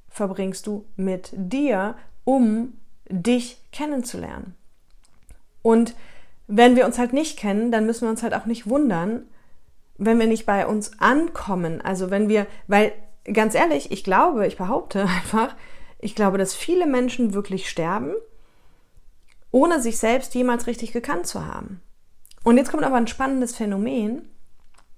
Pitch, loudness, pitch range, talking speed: 230 Hz, -22 LUFS, 205-250 Hz, 145 wpm